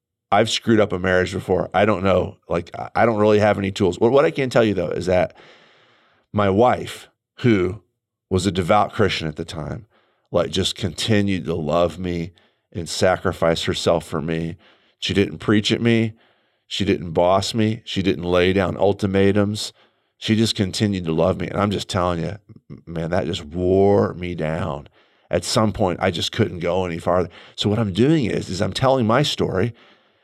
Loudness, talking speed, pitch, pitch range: -20 LUFS, 190 wpm, 95 Hz, 90-105 Hz